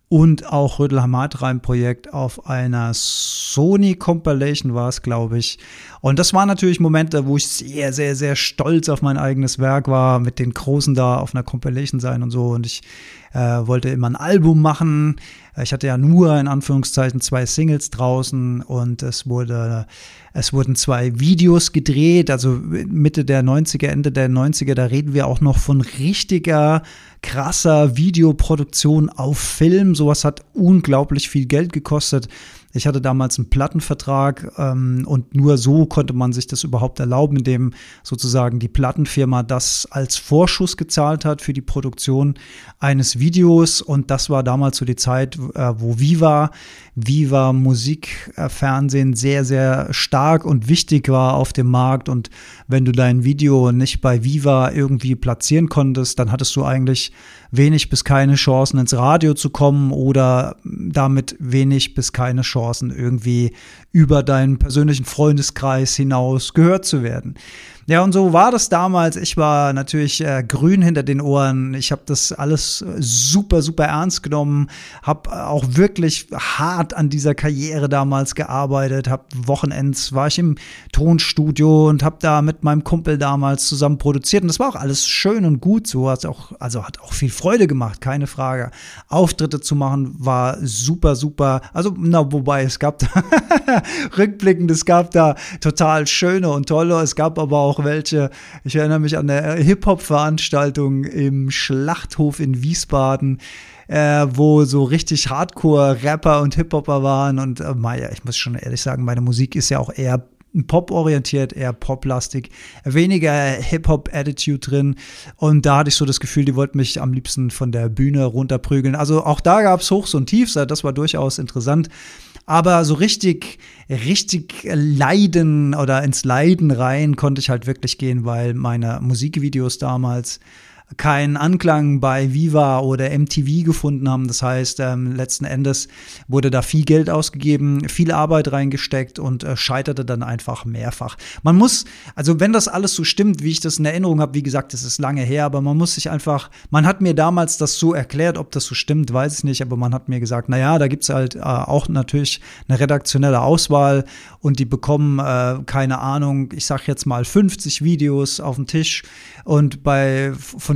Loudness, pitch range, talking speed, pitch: -17 LUFS, 130-155 Hz, 170 wpm, 140 Hz